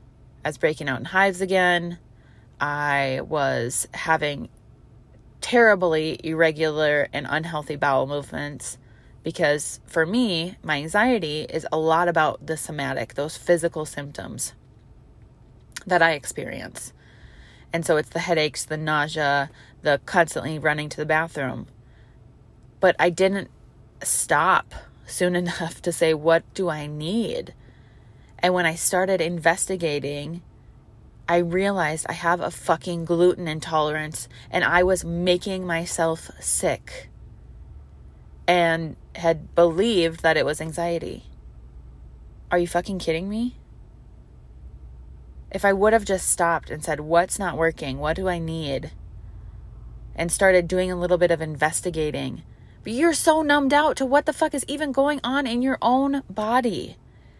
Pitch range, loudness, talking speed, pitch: 140-180 Hz, -23 LUFS, 135 wpm, 160 Hz